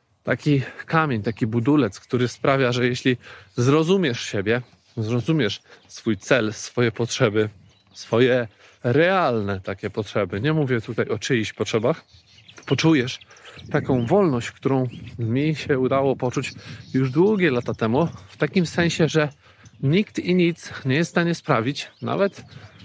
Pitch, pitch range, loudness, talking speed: 125 Hz, 115-150 Hz, -22 LUFS, 130 wpm